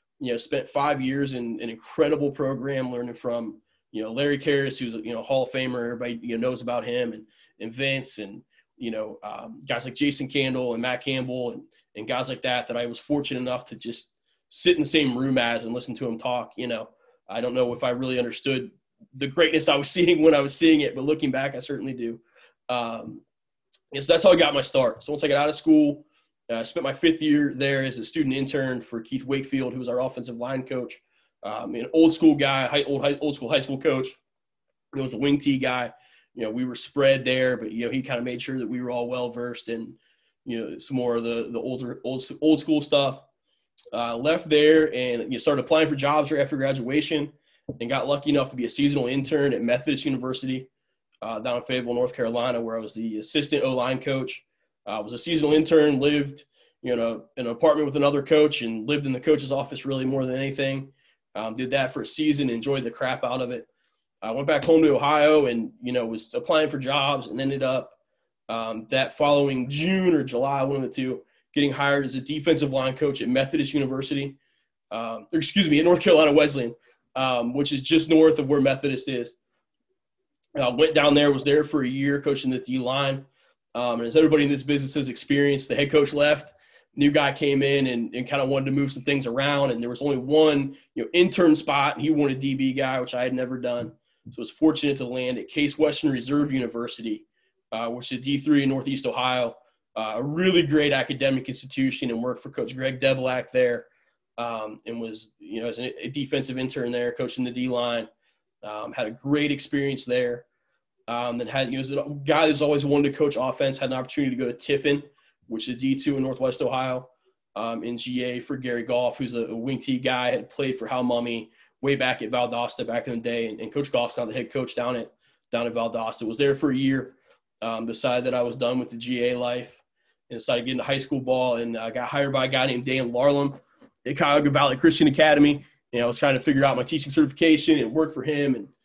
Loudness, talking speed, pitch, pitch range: -24 LUFS, 230 wpm, 135 Hz, 125-145 Hz